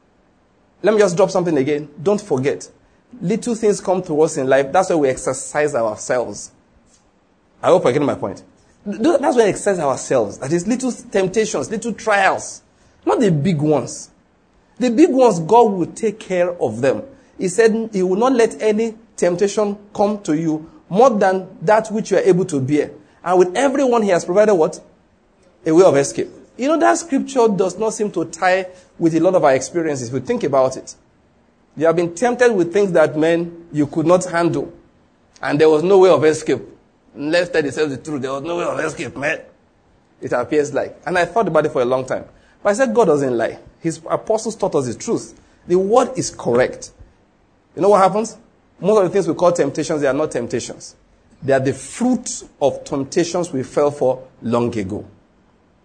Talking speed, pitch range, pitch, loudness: 200 wpm, 155-215 Hz, 180 Hz, -18 LUFS